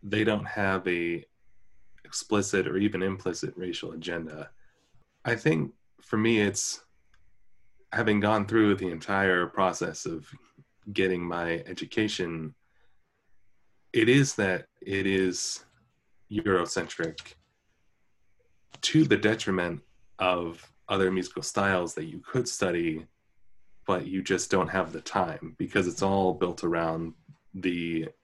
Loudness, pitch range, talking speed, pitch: -28 LUFS, 85-105 Hz, 115 wpm, 95 Hz